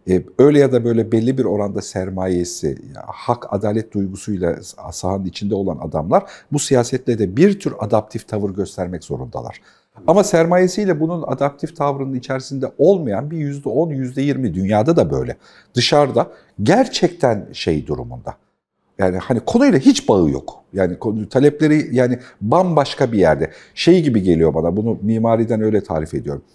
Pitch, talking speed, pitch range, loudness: 120 Hz, 145 wpm, 100-145 Hz, -18 LUFS